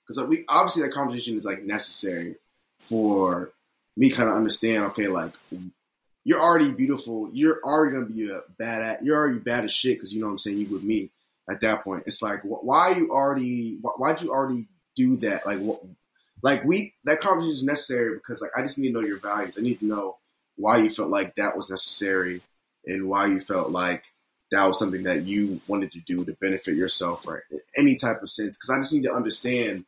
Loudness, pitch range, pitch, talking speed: -24 LUFS, 100-145 Hz, 115 Hz, 220 wpm